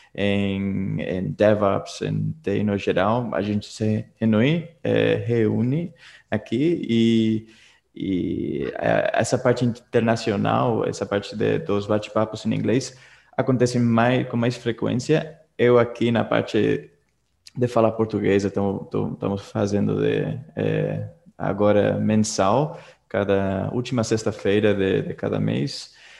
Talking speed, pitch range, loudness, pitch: 115 wpm, 100-120 Hz, -22 LUFS, 110 Hz